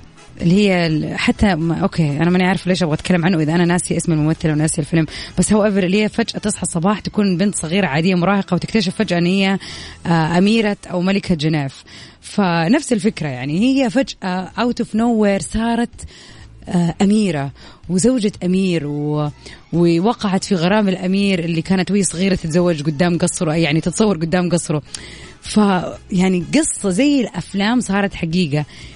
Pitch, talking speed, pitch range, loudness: 185 Hz, 155 wpm, 170-205 Hz, -17 LUFS